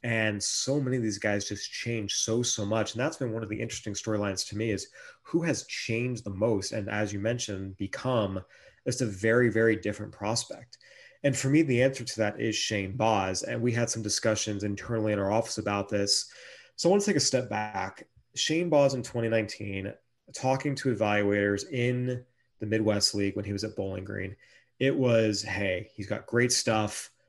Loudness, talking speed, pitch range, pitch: -29 LUFS, 200 wpm, 105-125 Hz, 110 Hz